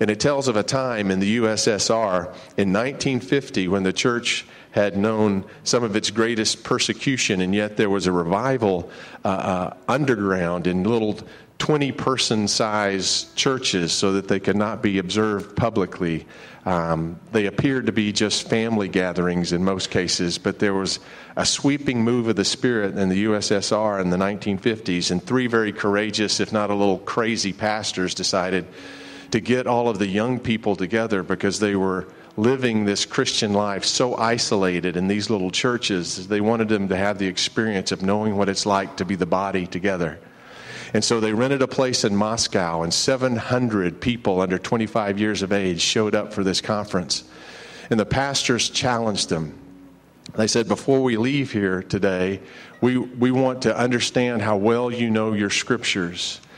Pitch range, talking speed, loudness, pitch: 95-120 Hz, 175 wpm, -22 LUFS, 105 Hz